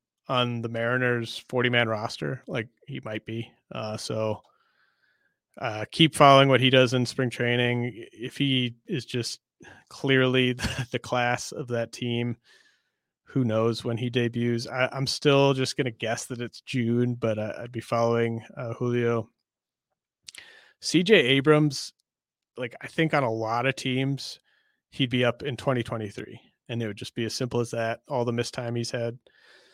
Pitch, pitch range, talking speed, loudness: 120 Hz, 115-130 Hz, 165 wpm, -26 LUFS